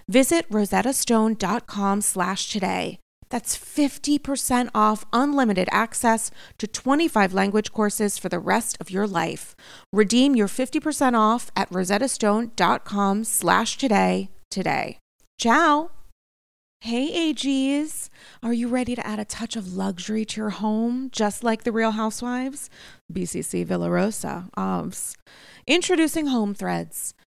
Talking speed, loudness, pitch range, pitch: 110 wpm, -23 LUFS, 200-255 Hz, 220 Hz